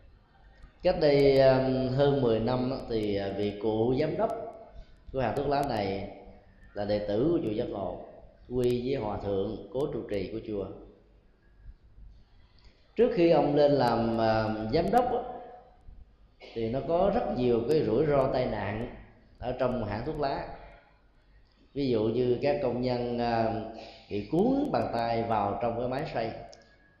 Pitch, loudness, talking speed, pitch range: 120 Hz, -28 LUFS, 150 wpm, 105-140 Hz